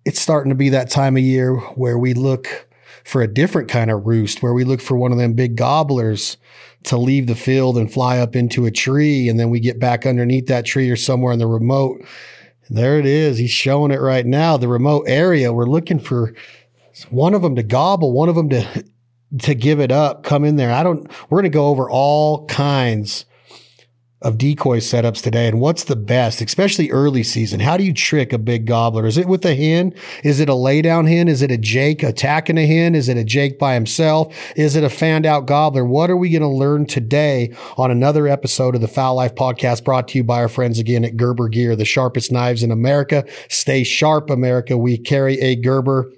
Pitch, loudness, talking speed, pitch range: 130 Hz, -16 LUFS, 220 wpm, 120-145 Hz